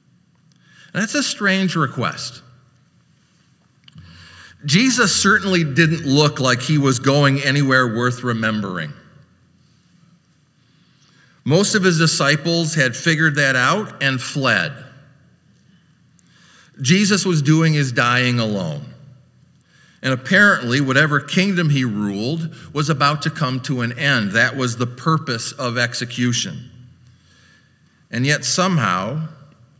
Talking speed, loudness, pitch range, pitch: 105 wpm, -17 LUFS, 125-165 Hz, 145 Hz